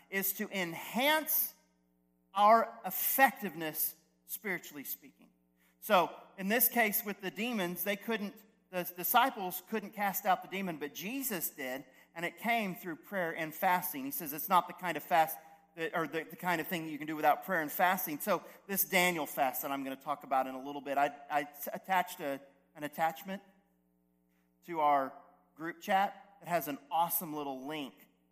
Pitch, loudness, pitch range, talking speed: 170 Hz, -33 LUFS, 145-195 Hz, 185 wpm